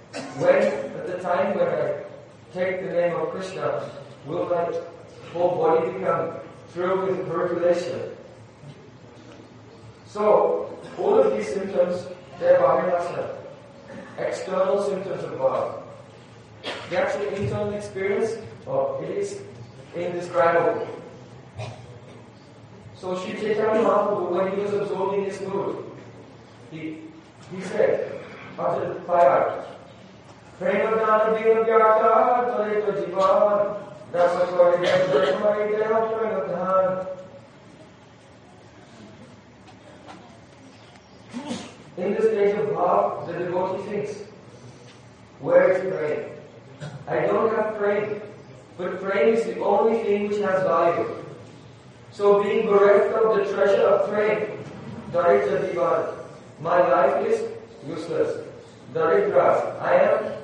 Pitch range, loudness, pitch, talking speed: 165-210 Hz, -23 LUFS, 190 Hz, 90 wpm